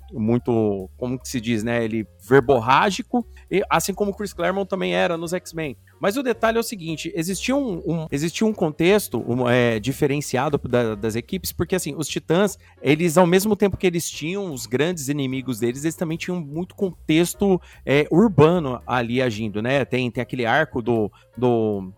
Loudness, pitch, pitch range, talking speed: -22 LUFS, 150 Hz, 120-185 Hz, 180 wpm